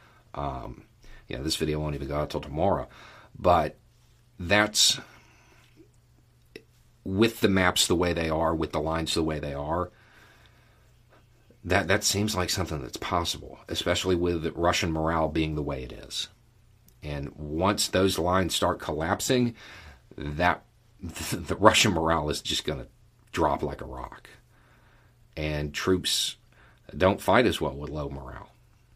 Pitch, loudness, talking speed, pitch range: 90 Hz, -26 LUFS, 145 wpm, 80-110 Hz